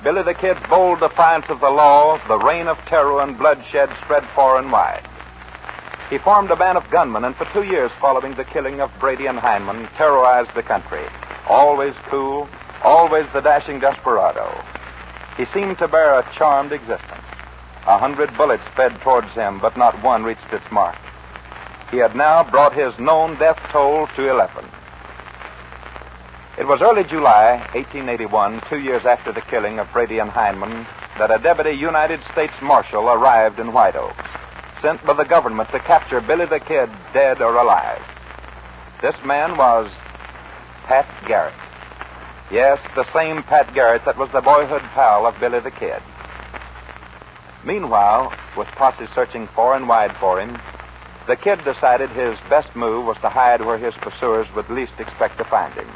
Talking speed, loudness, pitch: 165 wpm, -17 LUFS, 125 Hz